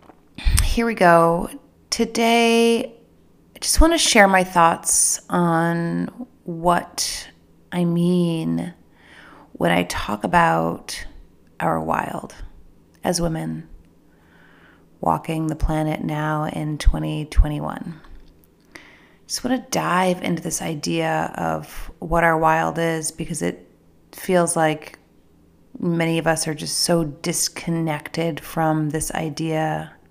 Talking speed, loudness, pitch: 110 wpm, -21 LUFS, 160 Hz